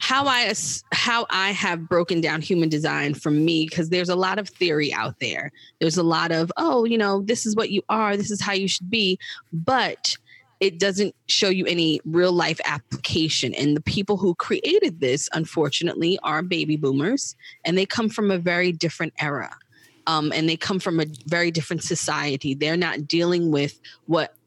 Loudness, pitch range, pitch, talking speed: -22 LUFS, 160-200 Hz, 175 Hz, 190 wpm